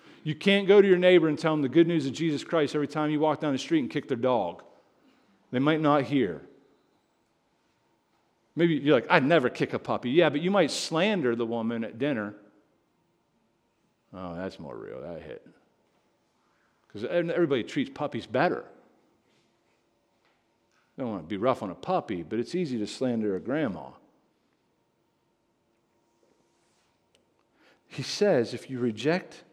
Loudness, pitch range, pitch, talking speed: -26 LUFS, 115-160 Hz, 140 Hz, 160 wpm